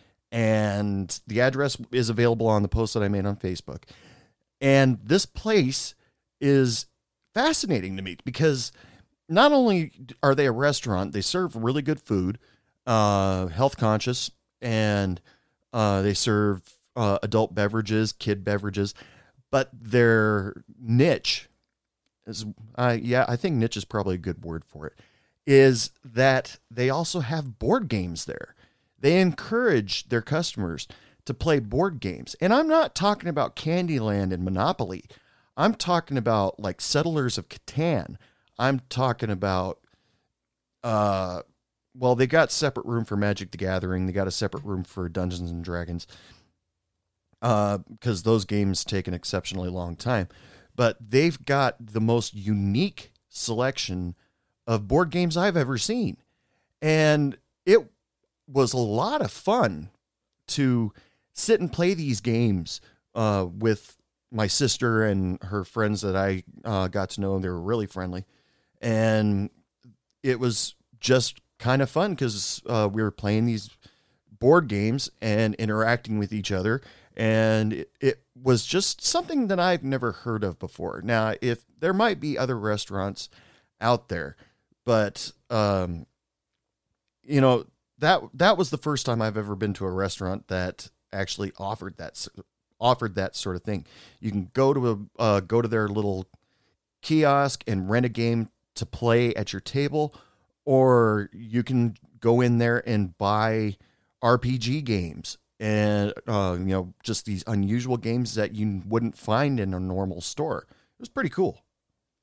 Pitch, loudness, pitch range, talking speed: 110 Hz, -25 LUFS, 100-130 Hz, 150 wpm